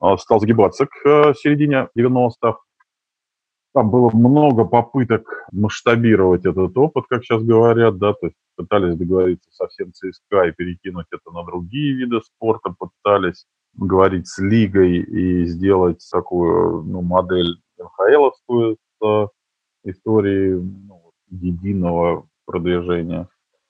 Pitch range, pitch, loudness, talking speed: 90-115 Hz, 100 Hz, -17 LUFS, 115 wpm